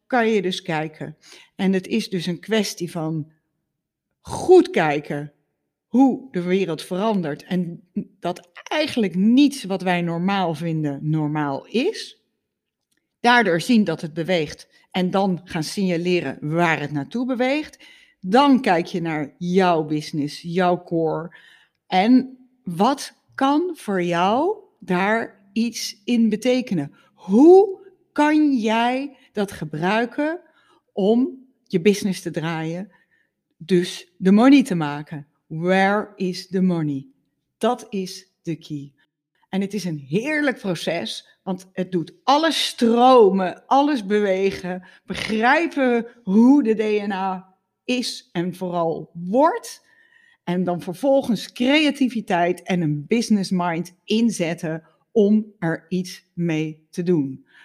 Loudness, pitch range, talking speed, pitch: -21 LUFS, 170-240 Hz, 120 wpm, 190 Hz